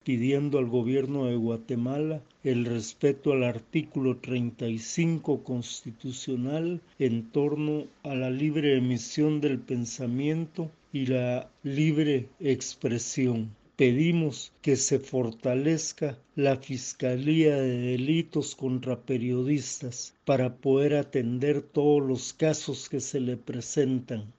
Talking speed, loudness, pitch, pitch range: 105 wpm, -28 LUFS, 135 Hz, 125-145 Hz